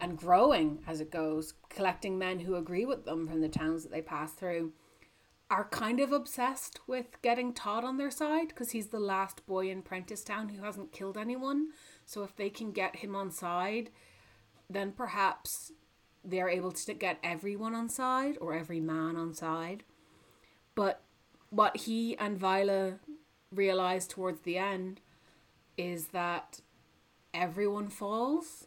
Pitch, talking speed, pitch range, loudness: 190 Hz, 155 wpm, 170-225 Hz, -34 LUFS